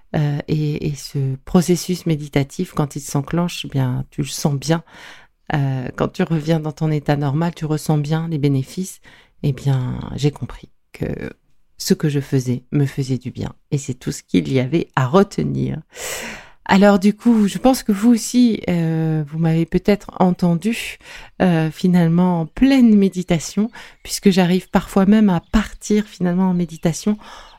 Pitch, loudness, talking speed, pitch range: 165 Hz, -19 LUFS, 165 wpm, 145-190 Hz